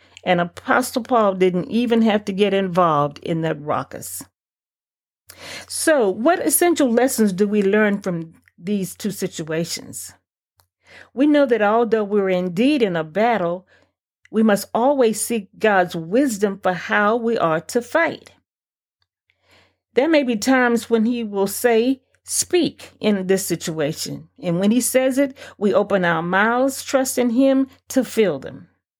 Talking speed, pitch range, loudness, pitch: 145 wpm, 185-250 Hz, -19 LUFS, 215 Hz